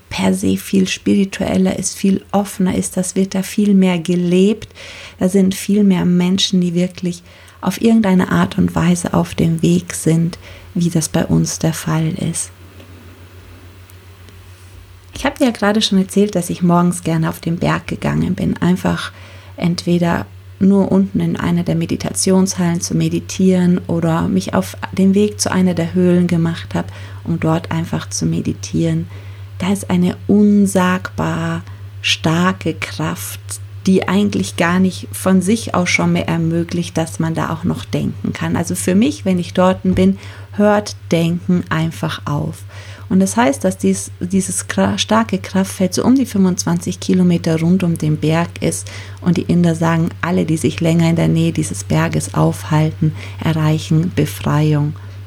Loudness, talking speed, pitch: -16 LUFS, 160 wpm, 165 Hz